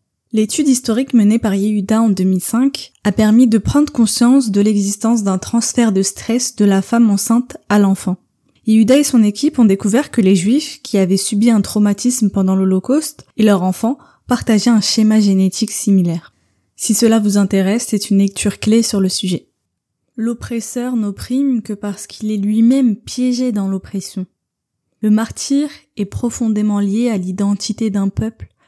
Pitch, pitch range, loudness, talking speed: 215 Hz, 200-235 Hz, -15 LUFS, 165 wpm